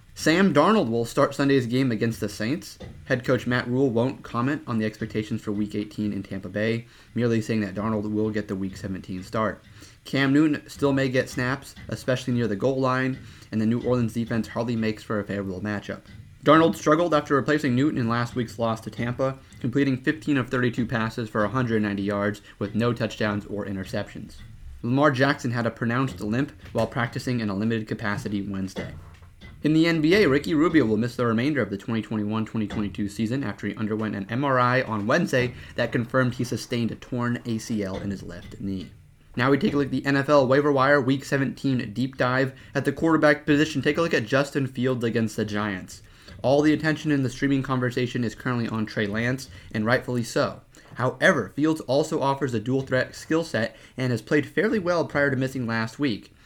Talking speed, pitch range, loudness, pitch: 200 wpm, 105-135 Hz, -25 LUFS, 120 Hz